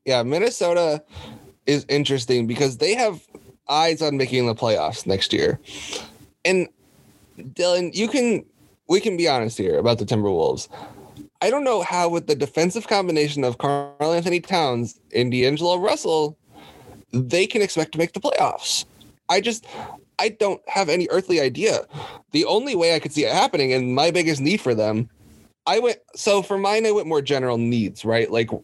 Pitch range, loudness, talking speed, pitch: 125-180 Hz, -21 LUFS, 170 wpm, 150 Hz